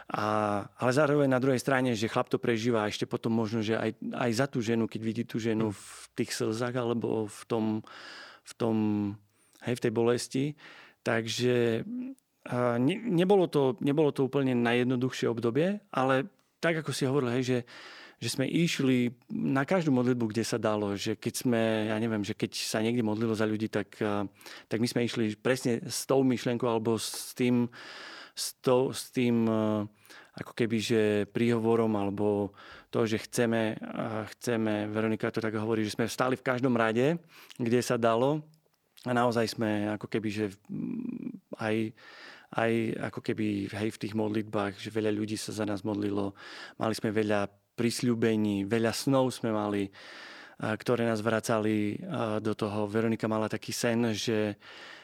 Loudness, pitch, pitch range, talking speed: -30 LUFS, 115 Hz, 110-125 Hz, 165 wpm